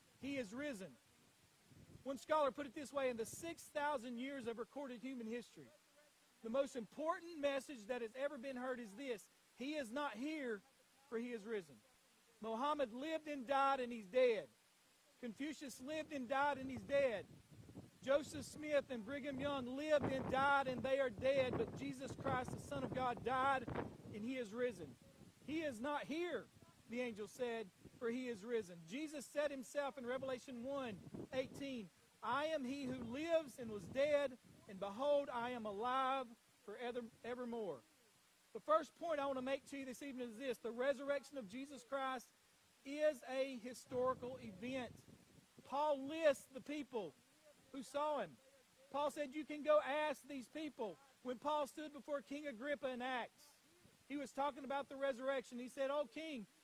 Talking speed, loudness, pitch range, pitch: 170 wpm, -44 LUFS, 245-285 Hz, 270 Hz